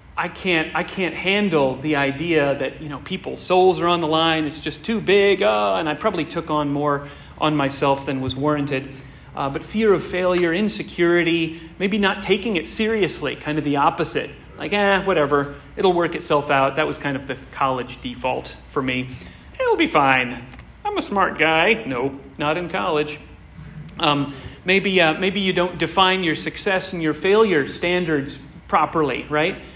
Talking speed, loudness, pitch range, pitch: 180 wpm, -20 LUFS, 145-185 Hz, 160 Hz